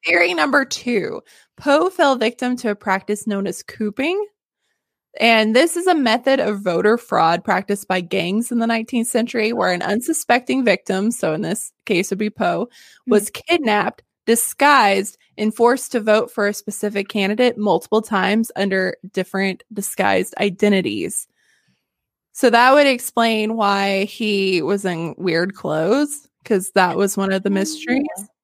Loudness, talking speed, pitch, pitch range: -18 LUFS, 155 wpm, 215 Hz, 195-240 Hz